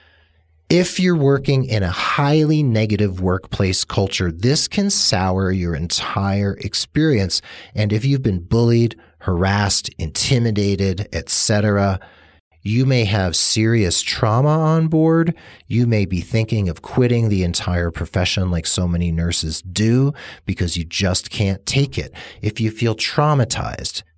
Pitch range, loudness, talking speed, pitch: 90-120 Hz, -18 LUFS, 135 wpm, 105 Hz